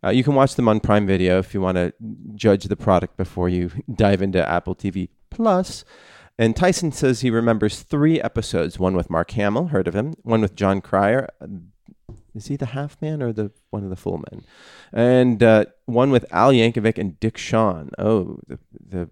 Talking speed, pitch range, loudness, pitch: 200 wpm, 95-125 Hz, -20 LUFS, 105 Hz